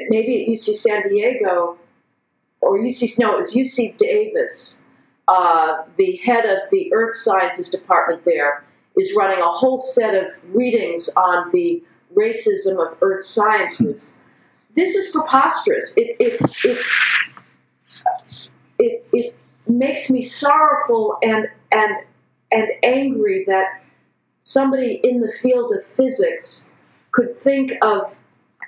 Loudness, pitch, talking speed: -18 LUFS, 250 Hz, 125 wpm